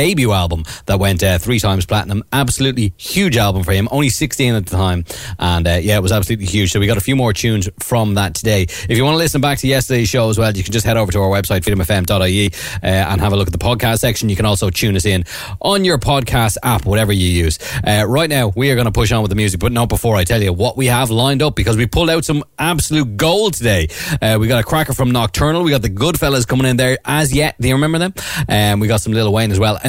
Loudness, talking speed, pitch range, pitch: -15 LUFS, 275 wpm, 100-130 Hz, 115 Hz